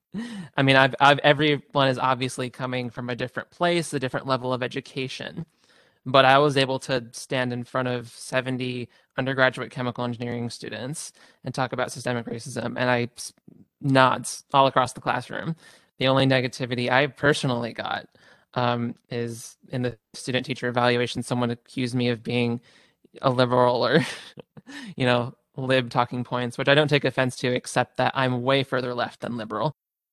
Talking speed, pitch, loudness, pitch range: 165 wpm, 130 Hz, -24 LUFS, 125-135 Hz